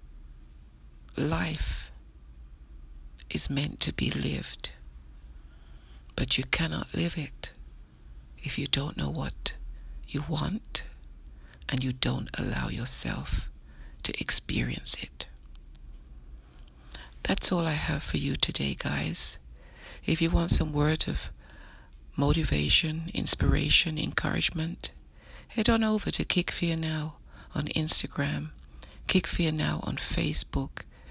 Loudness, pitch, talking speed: -29 LUFS, 65 Hz, 110 wpm